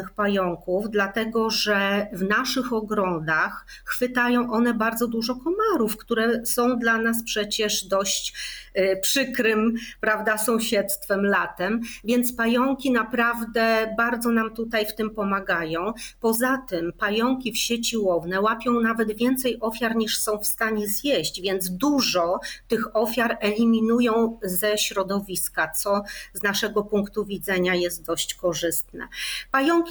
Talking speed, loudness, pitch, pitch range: 125 wpm, -23 LUFS, 220 Hz, 200-235 Hz